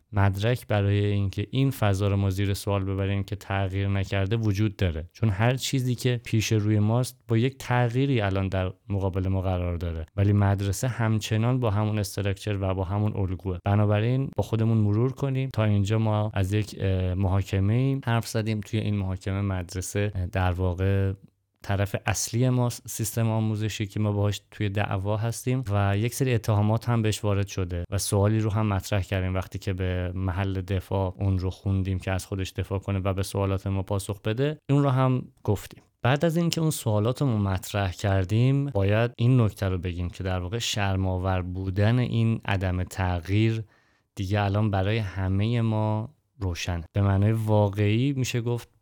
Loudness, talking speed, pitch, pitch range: -26 LUFS, 175 wpm, 105 Hz, 95-115 Hz